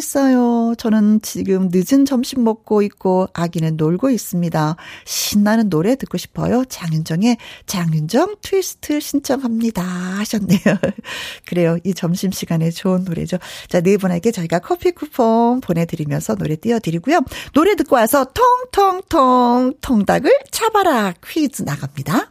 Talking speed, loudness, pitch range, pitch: 310 characters per minute, -17 LUFS, 180-265 Hz, 215 Hz